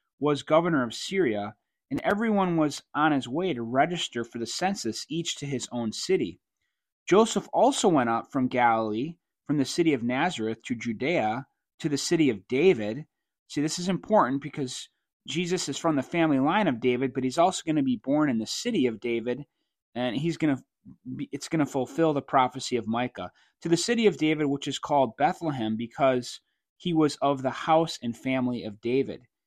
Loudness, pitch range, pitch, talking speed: -27 LUFS, 125-170 Hz, 140 Hz, 195 wpm